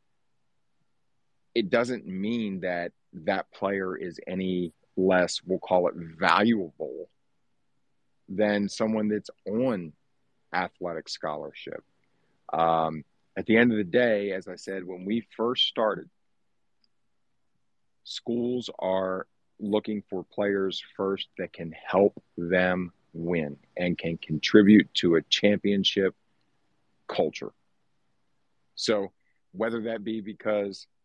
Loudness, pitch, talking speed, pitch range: -27 LUFS, 95 Hz, 110 wpm, 90-105 Hz